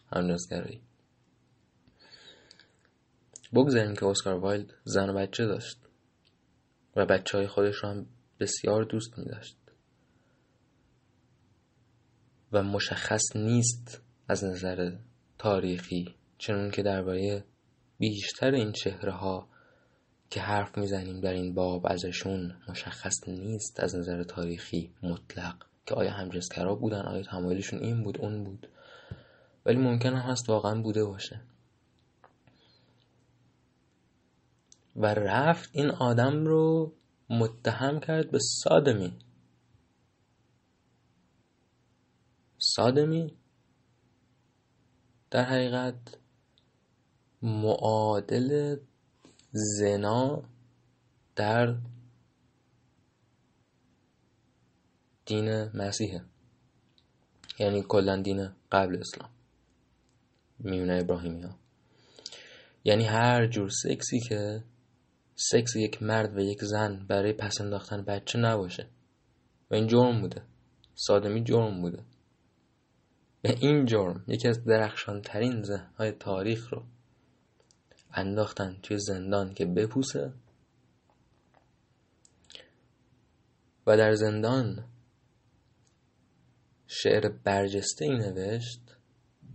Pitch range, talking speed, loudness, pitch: 95-120 Hz, 85 wpm, -29 LUFS, 110 Hz